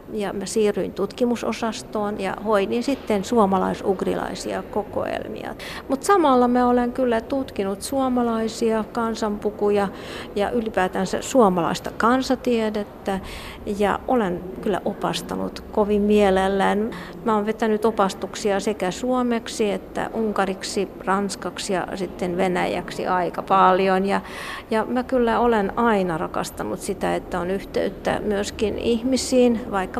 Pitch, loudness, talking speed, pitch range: 210 Hz, -22 LUFS, 110 wpm, 195-235 Hz